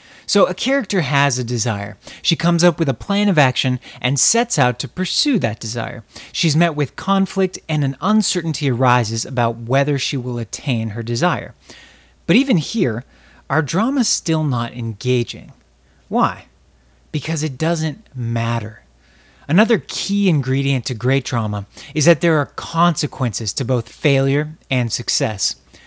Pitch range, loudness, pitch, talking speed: 120-170 Hz, -18 LUFS, 140 Hz, 150 wpm